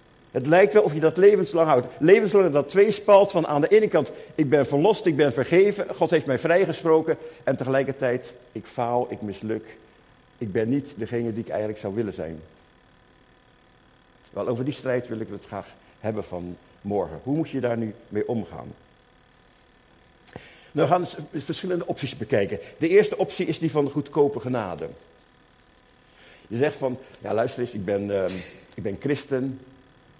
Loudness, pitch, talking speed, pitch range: -23 LUFS, 130 Hz, 175 wpm, 115-160 Hz